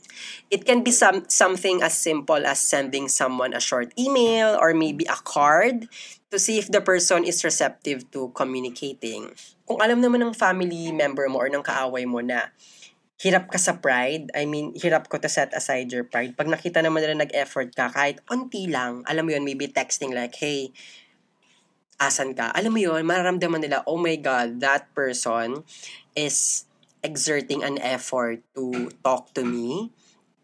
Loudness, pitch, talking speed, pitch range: -23 LUFS, 150 Hz, 170 wpm, 130-180 Hz